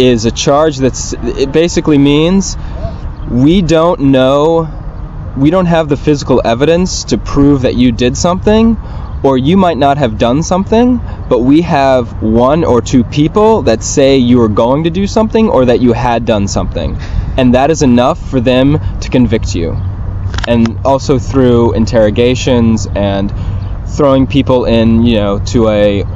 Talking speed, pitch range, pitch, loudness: 165 wpm, 110-145 Hz, 125 Hz, -10 LUFS